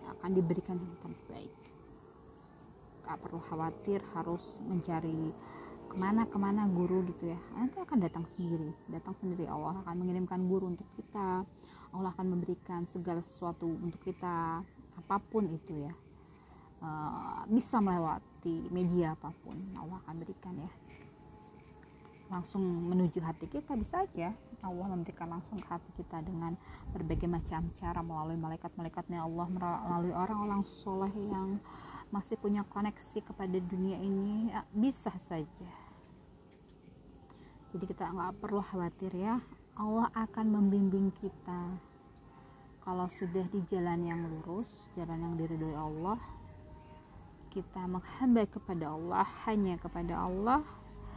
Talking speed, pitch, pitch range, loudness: 120 wpm, 180 Hz, 170-200 Hz, -37 LUFS